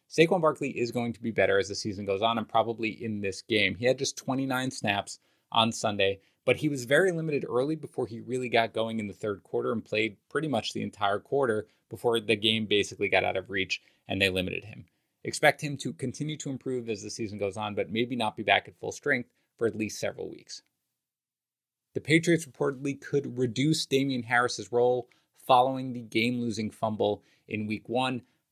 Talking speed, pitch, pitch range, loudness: 205 wpm, 115 Hz, 105-130 Hz, -29 LUFS